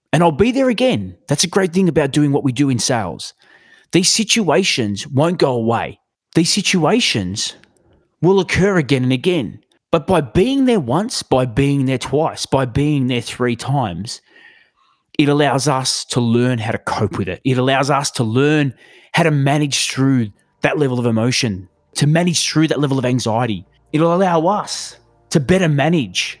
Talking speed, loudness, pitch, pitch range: 175 wpm, -16 LUFS, 145 Hz, 125-170 Hz